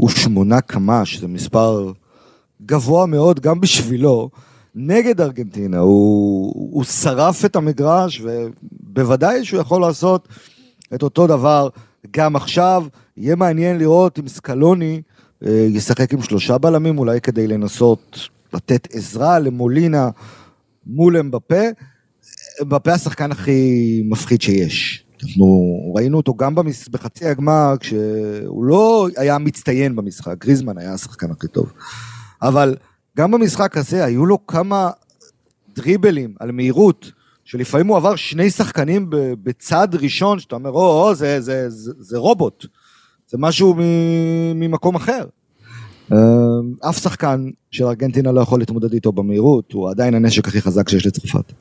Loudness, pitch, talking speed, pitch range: -16 LUFS, 135 Hz, 130 wpm, 115-165 Hz